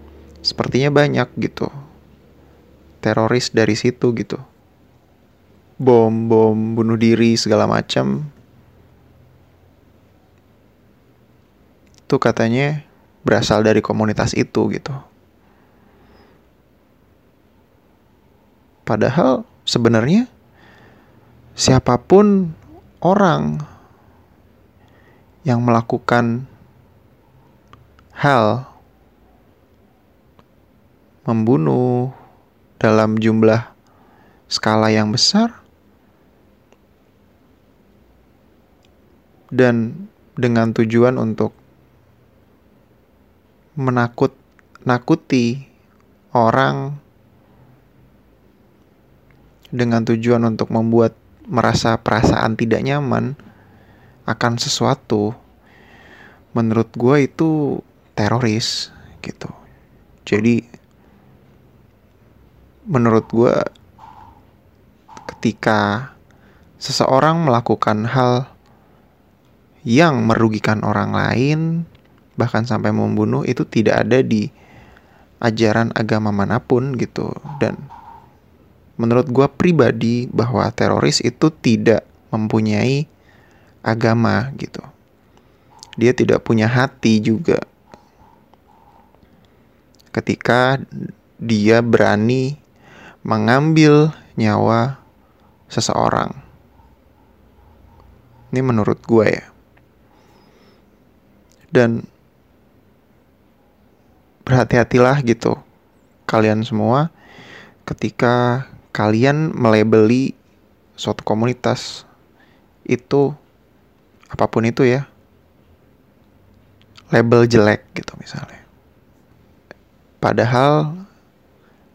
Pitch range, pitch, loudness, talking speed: 110-125 Hz, 115 Hz, -17 LUFS, 60 wpm